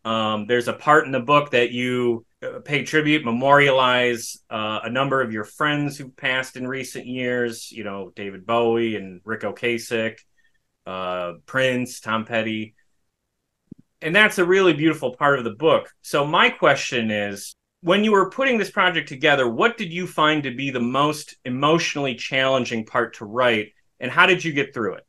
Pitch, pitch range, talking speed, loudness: 130 Hz, 115-150 Hz, 175 wpm, -21 LUFS